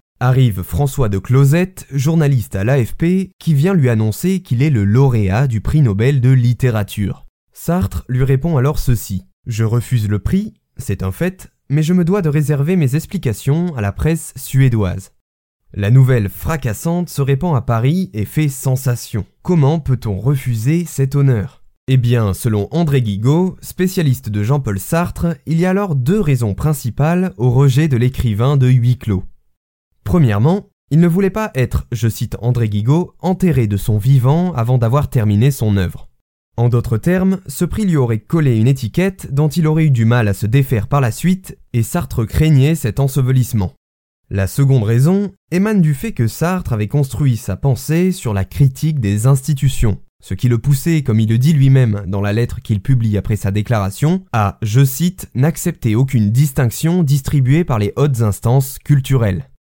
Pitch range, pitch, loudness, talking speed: 110-155 Hz, 130 Hz, -16 LUFS, 175 wpm